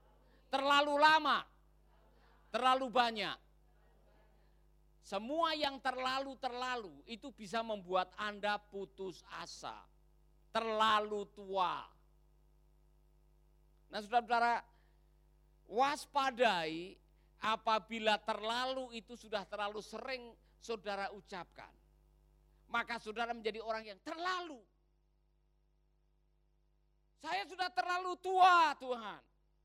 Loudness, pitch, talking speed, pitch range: -36 LUFS, 215 Hz, 75 wpm, 165-255 Hz